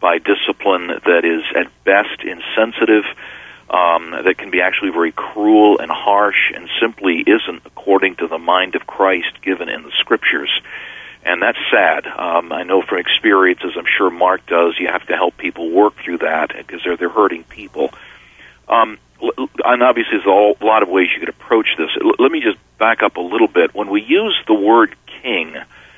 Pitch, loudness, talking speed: 110 Hz, -15 LUFS, 185 wpm